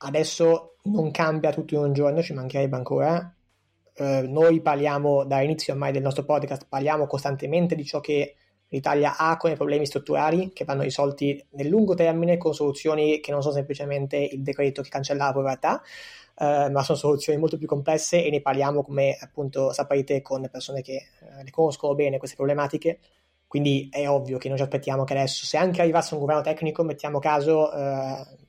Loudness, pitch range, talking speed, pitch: -24 LUFS, 140-155 Hz, 185 wpm, 145 Hz